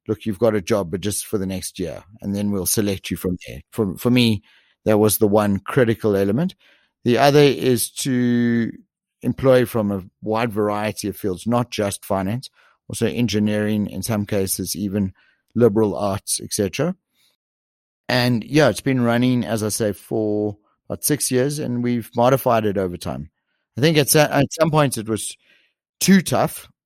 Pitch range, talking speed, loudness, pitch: 100-125 Hz, 175 wpm, -20 LUFS, 110 Hz